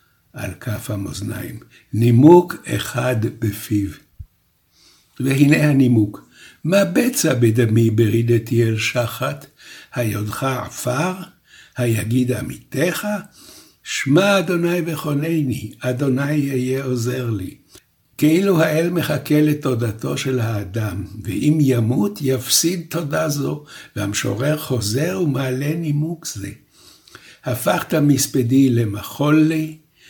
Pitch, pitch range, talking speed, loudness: 130 Hz, 115-155 Hz, 90 wpm, -19 LUFS